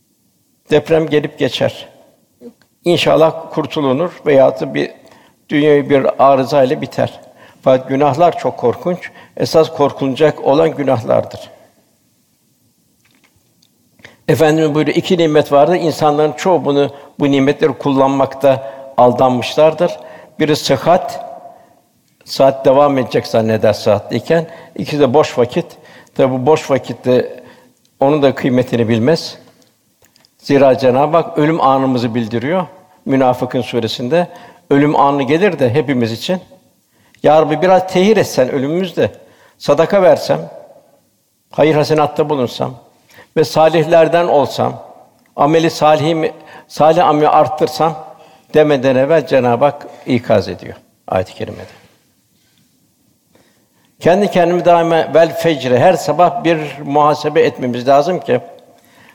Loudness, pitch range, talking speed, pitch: -13 LUFS, 135-165 Hz, 110 wpm, 150 Hz